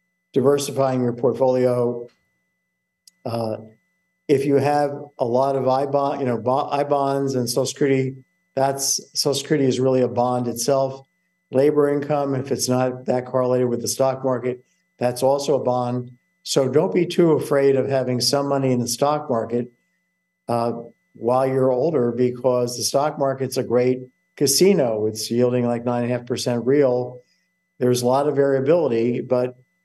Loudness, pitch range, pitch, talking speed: -21 LUFS, 125-145 Hz, 130 Hz, 165 wpm